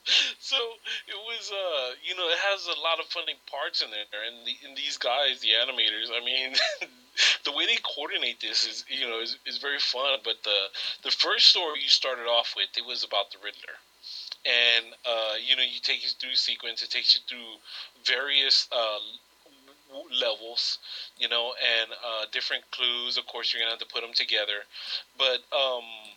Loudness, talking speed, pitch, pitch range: -25 LUFS, 190 wpm, 120 Hz, 115-165 Hz